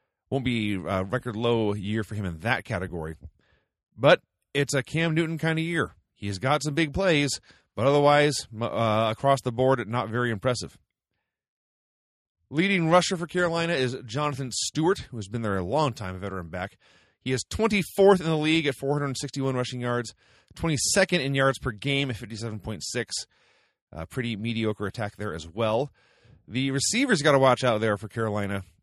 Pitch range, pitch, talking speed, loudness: 105-145 Hz, 125 Hz, 175 wpm, -26 LUFS